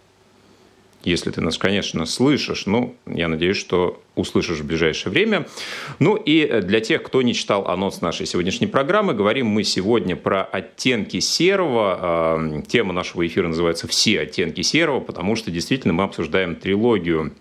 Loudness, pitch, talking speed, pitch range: -20 LUFS, 85 Hz, 150 wpm, 80-90 Hz